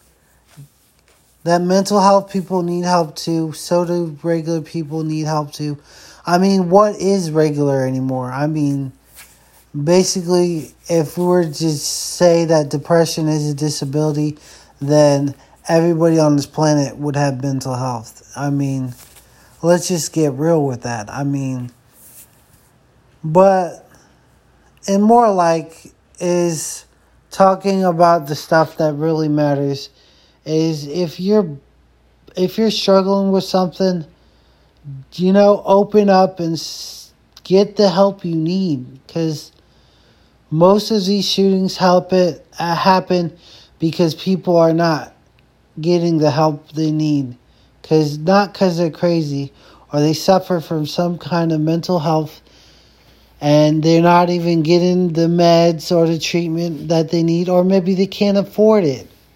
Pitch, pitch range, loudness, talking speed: 165 Hz, 145-180 Hz, -16 LUFS, 135 wpm